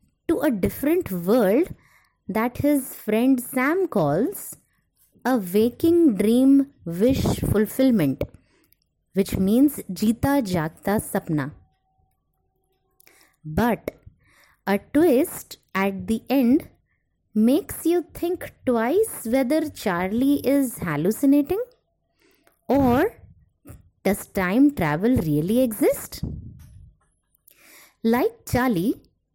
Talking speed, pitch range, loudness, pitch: 85 wpm, 195-285 Hz, -22 LUFS, 240 Hz